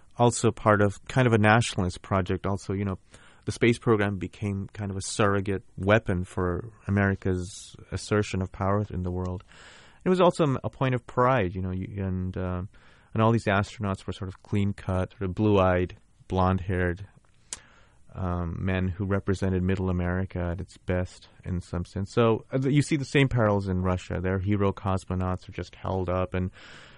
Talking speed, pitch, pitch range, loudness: 175 wpm, 95 Hz, 90-110 Hz, -27 LUFS